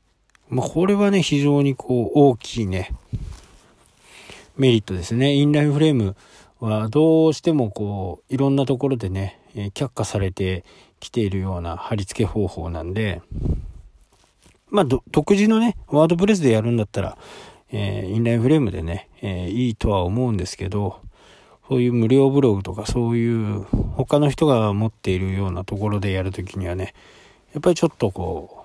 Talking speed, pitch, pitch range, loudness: 340 characters per minute, 115 Hz, 95-140 Hz, -21 LUFS